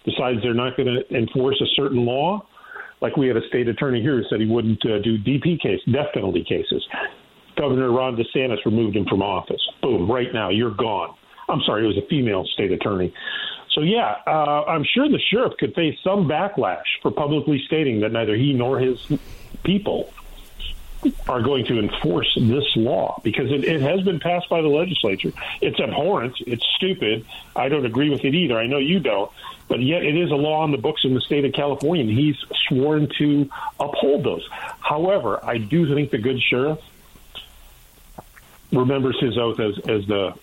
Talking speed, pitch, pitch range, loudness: 190 wpm, 135 Hz, 120-150 Hz, -21 LUFS